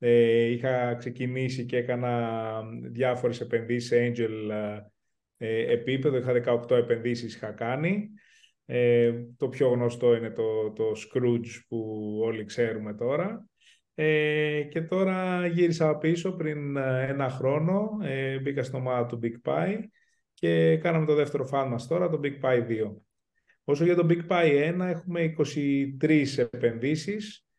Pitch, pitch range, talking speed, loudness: 130 Hz, 115-155 Hz, 135 wpm, -27 LUFS